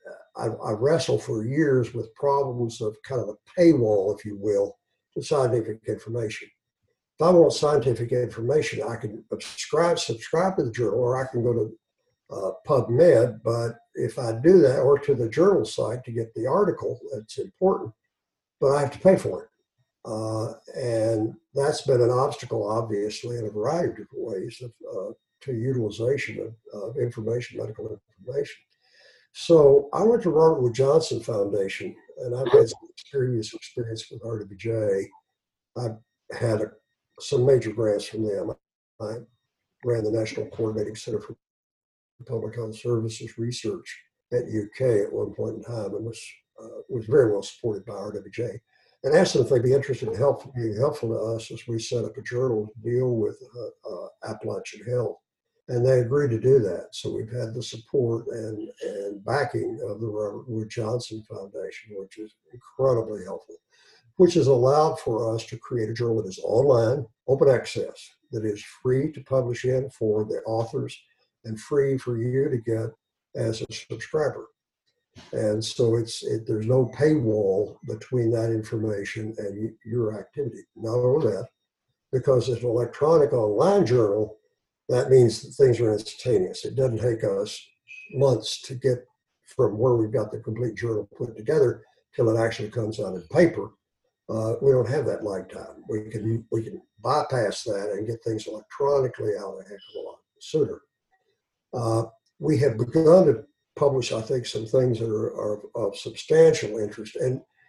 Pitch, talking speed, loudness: 125 Hz, 170 wpm, -25 LUFS